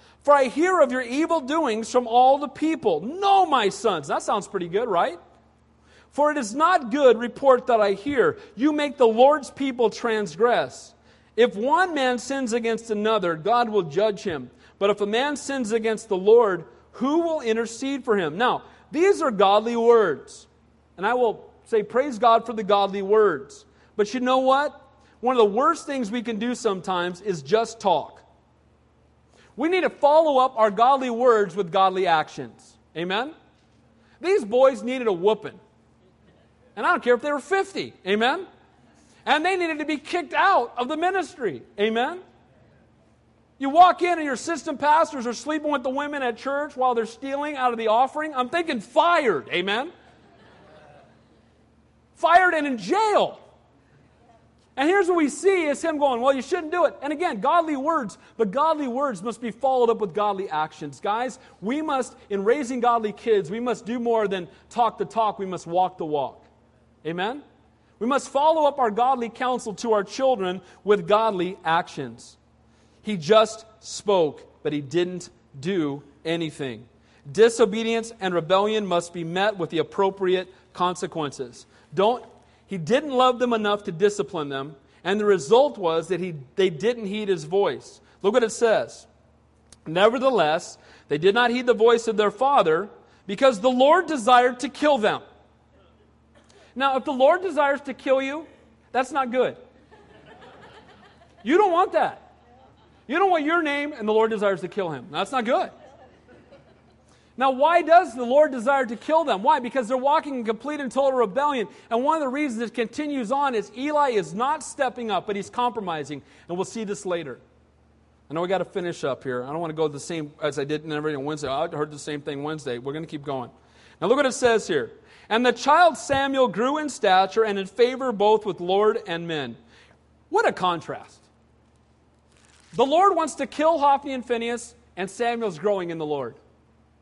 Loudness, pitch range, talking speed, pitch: -23 LUFS, 195-285 Hz, 180 wpm, 235 Hz